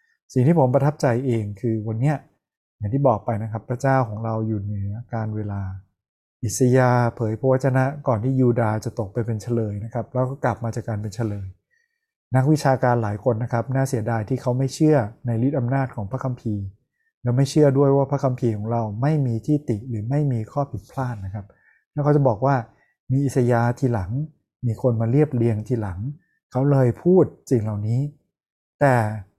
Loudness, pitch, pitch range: -22 LUFS, 125 Hz, 110-135 Hz